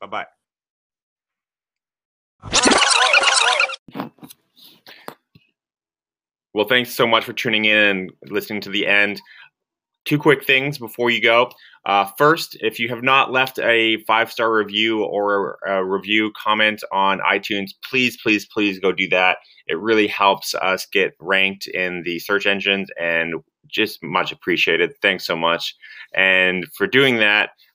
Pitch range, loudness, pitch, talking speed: 95-115 Hz, -18 LUFS, 105 Hz, 140 wpm